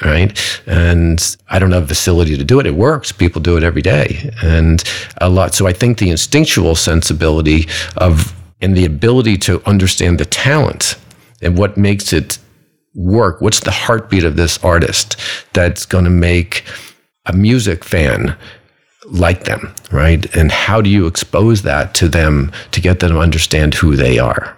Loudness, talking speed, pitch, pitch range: -13 LUFS, 170 wpm, 90 Hz, 80-100 Hz